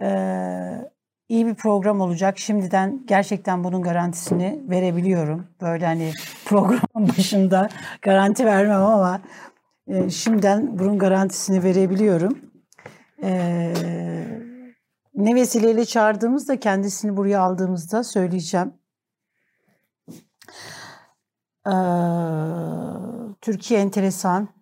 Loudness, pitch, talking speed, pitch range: -21 LUFS, 195 Hz, 80 wpm, 180-215 Hz